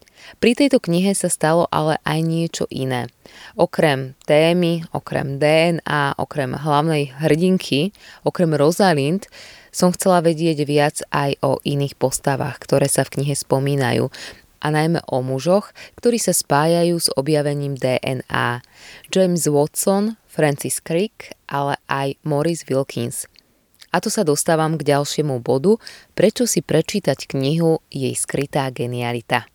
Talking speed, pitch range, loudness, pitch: 130 wpm, 140-170 Hz, -19 LUFS, 150 Hz